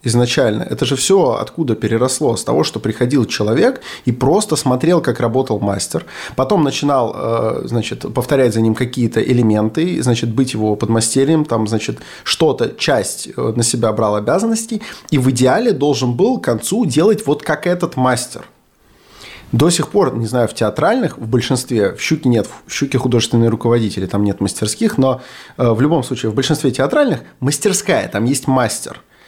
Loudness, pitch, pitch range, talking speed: -16 LUFS, 125 Hz, 115-145 Hz, 160 wpm